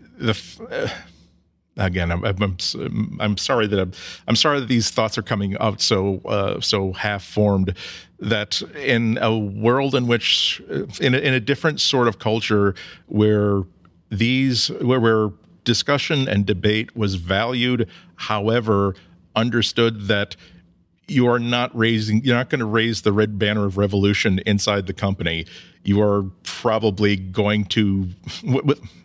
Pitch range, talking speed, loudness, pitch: 95-115 Hz, 155 wpm, -20 LUFS, 105 Hz